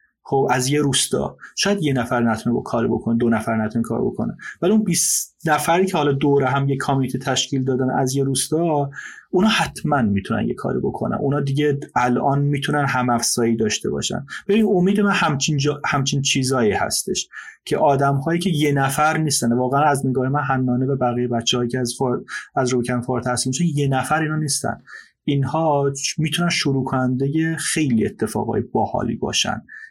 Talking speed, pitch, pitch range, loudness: 170 wpm, 140 Hz, 125-150 Hz, -20 LUFS